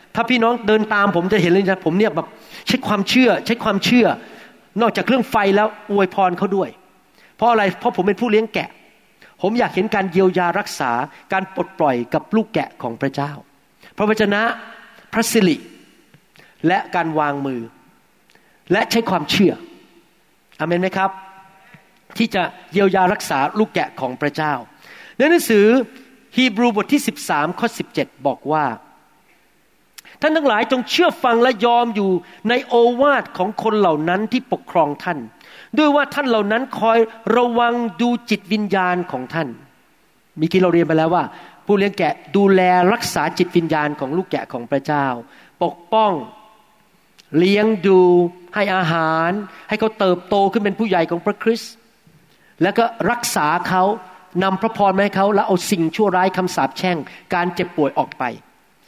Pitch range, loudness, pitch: 175-225 Hz, -18 LUFS, 195 Hz